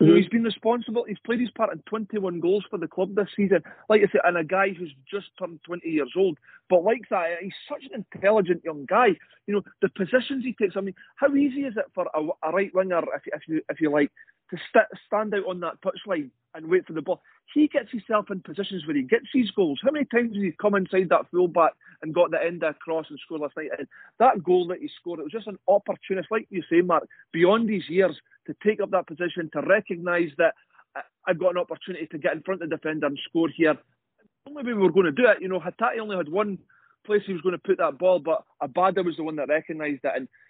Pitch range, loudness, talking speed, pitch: 170-210 Hz, -25 LUFS, 260 wpm, 185 Hz